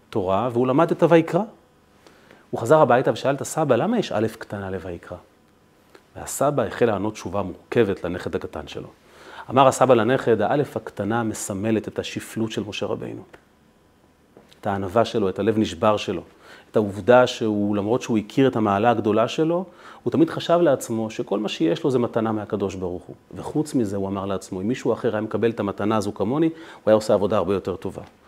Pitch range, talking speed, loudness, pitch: 100-125 Hz, 185 wpm, -22 LUFS, 110 Hz